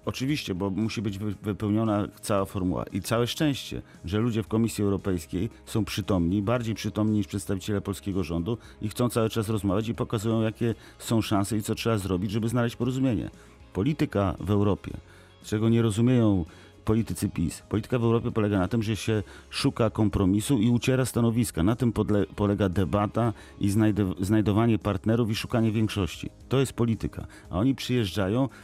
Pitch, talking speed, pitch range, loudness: 105 Hz, 160 wpm, 100-115 Hz, -27 LUFS